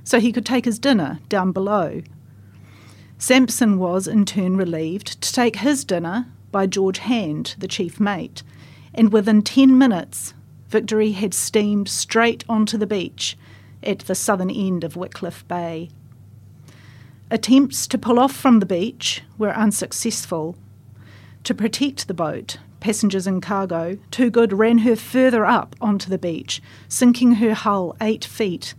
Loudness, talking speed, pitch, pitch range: -19 LUFS, 150 wpm, 200 Hz, 160-225 Hz